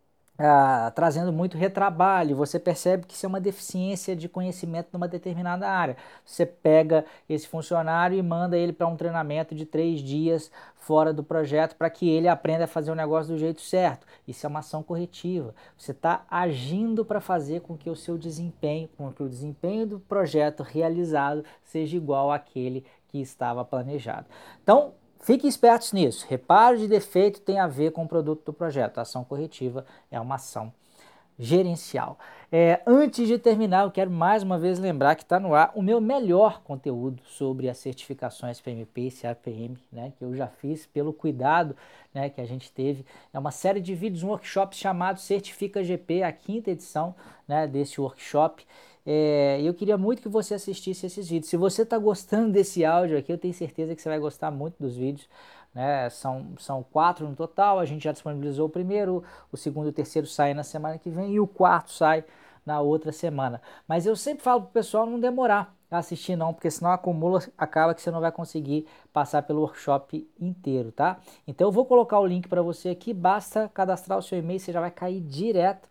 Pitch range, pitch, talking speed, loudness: 150-185 Hz, 165 Hz, 195 wpm, -26 LUFS